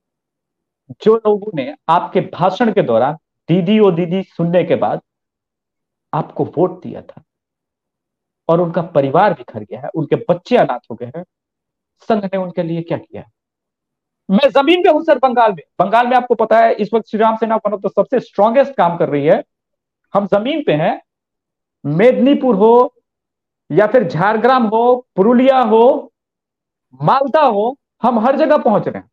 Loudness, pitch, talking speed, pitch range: -14 LUFS, 215 Hz, 165 wpm, 180-250 Hz